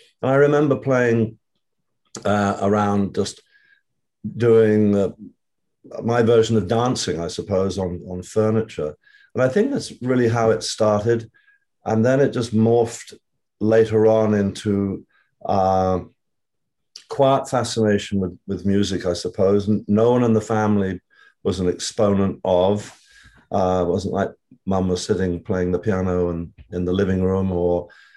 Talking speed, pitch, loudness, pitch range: 145 wpm, 105 Hz, -20 LUFS, 95-115 Hz